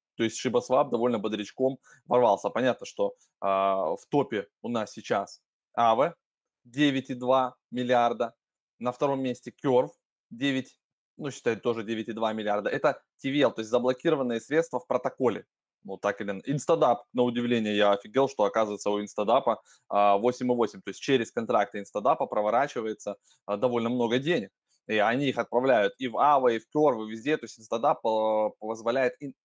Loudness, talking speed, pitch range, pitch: -27 LUFS, 155 wpm, 110-130 Hz, 120 Hz